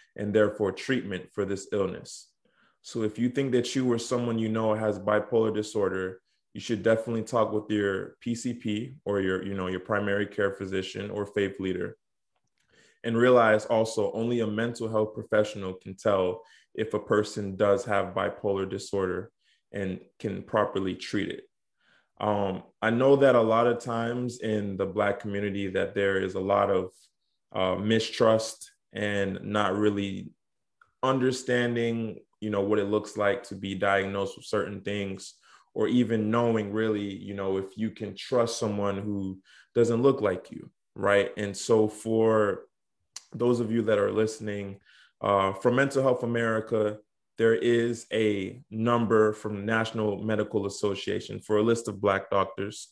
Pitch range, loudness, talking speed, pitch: 100-115 Hz, -28 LUFS, 160 wpm, 105 Hz